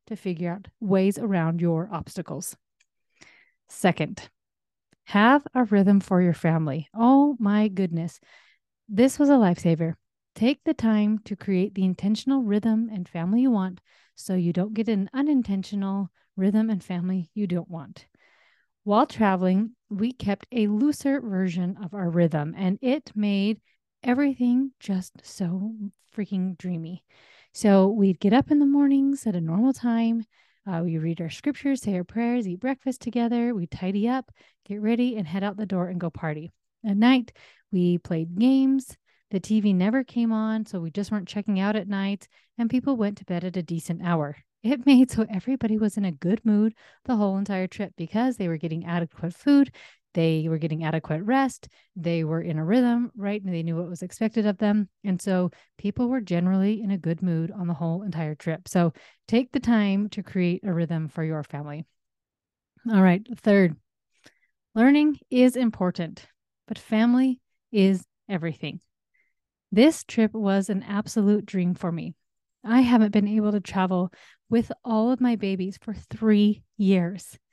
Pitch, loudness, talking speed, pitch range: 200 Hz, -24 LUFS, 170 wpm, 180-230 Hz